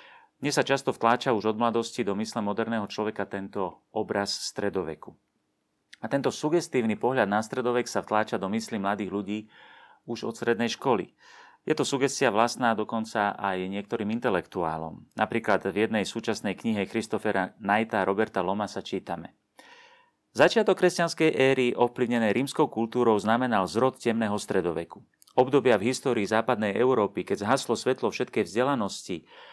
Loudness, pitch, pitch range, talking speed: -27 LUFS, 115 Hz, 105-125 Hz, 140 wpm